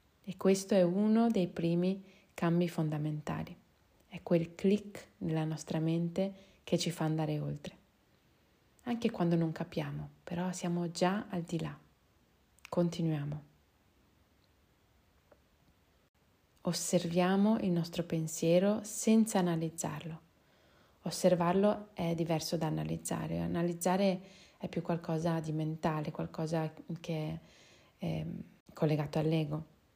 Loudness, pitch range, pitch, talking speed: -34 LUFS, 160-185 Hz, 170 Hz, 105 wpm